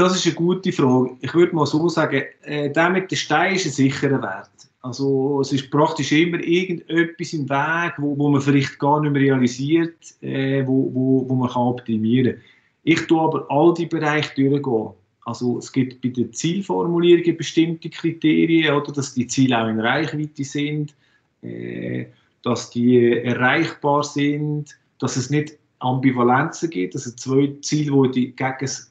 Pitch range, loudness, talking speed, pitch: 125-155 Hz, -20 LUFS, 170 wpm, 140 Hz